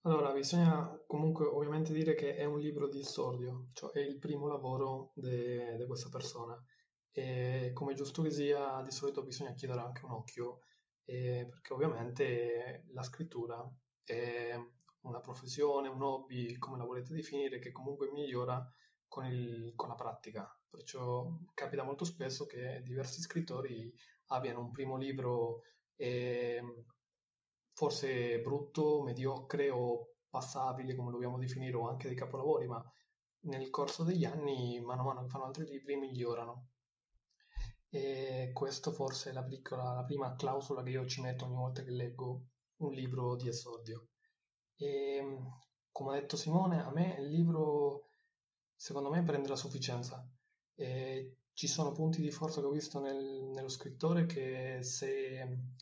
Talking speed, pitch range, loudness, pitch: 150 wpm, 125-145 Hz, -39 LUFS, 135 Hz